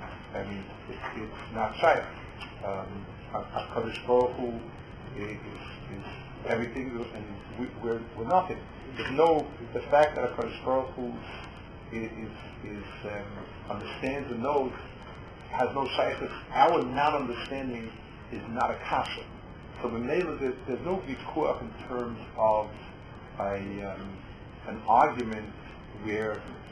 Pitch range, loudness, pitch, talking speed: 105-125 Hz, -31 LUFS, 115 Hz, 125 wpm